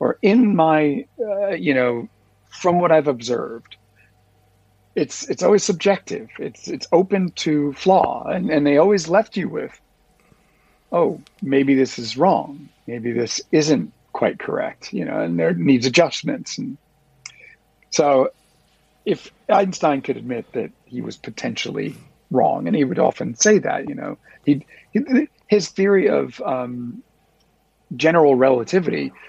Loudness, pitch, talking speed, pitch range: -19 LUFS, 155 Hz, 140 wpm, 125-200 Hz